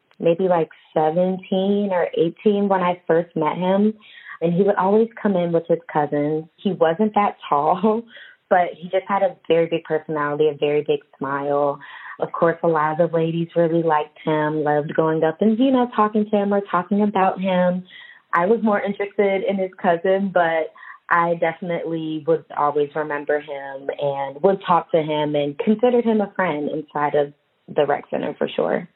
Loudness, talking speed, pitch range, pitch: -21 LUFS, 185 wpm, 155-195 Hz, 170 Hz